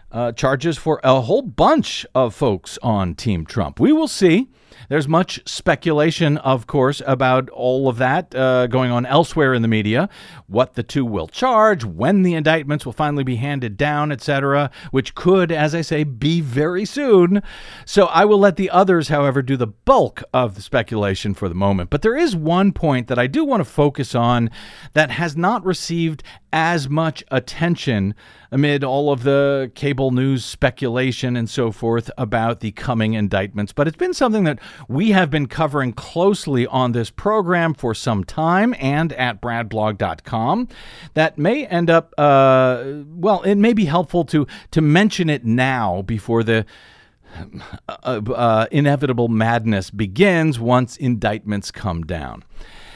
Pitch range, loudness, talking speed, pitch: 120-165 Hz, -18 LUFS, 165 wpm, 140 Hz